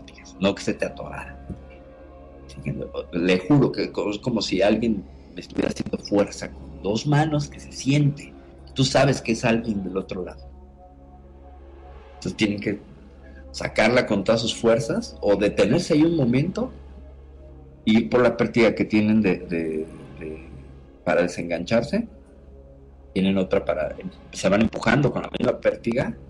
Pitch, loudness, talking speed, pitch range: 80 Hz, -23 LUFS, 145 wpm, 70-110 Hz